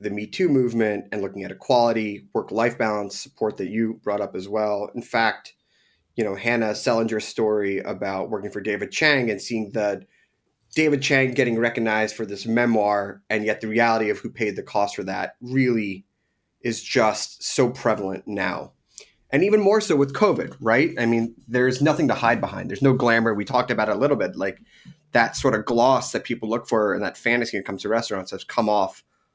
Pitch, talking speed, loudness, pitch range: 110 Hz, 205 wpm, -23 LUFS, 105-120 Hz